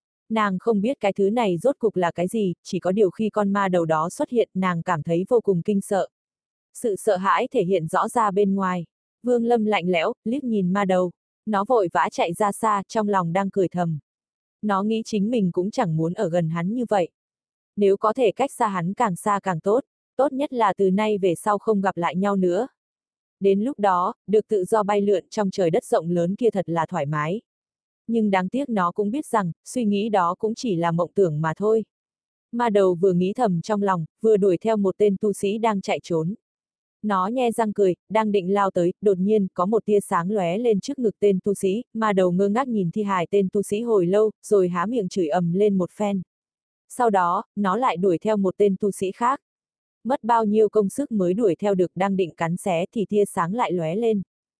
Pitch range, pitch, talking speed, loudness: 185-220 Hz, 200 Hz, 235 wpm, -22 LUFS